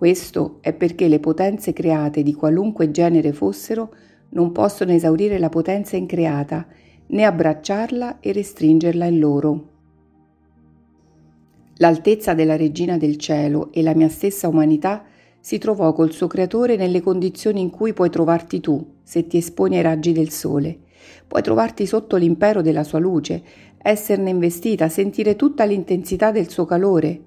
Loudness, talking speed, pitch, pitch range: -19 LUFS, 145 wpm, 170 Hz, 155-195 Hz